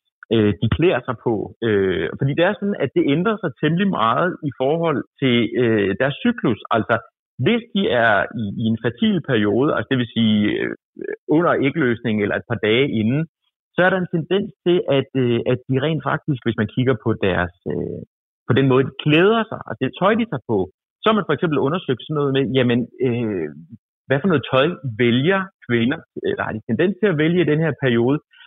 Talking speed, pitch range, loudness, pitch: 215 wpm, 115-175 Hz, -20 LUFS, 135 Hz